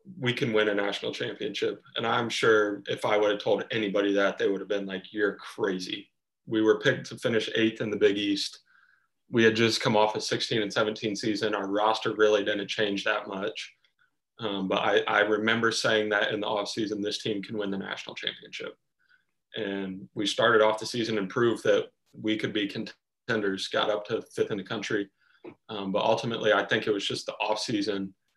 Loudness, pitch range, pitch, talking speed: -27 LUFS, 100-115 Hz, 110 Hz, 210 wpm